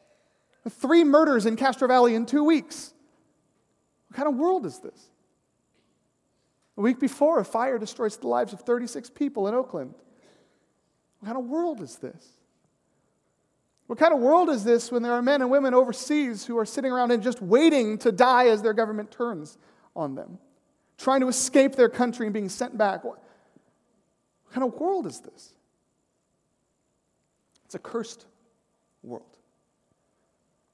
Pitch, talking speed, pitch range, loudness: 250 Hz, 155 wpm, 230-285 Hz, -24 LUFS